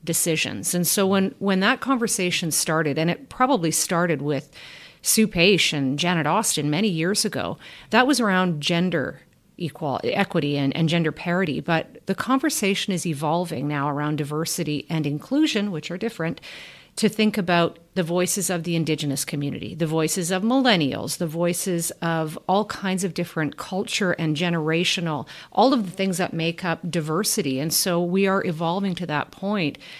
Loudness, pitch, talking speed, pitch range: -23 LUFS, 175 Hz, 165 wpm, 160-195 Hz